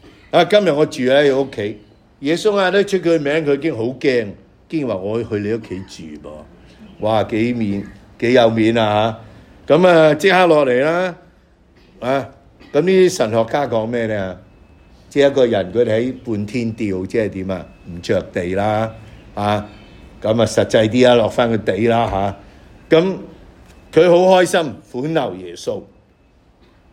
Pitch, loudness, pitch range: 115 Hz, -16 LUFS, 100-145 Hz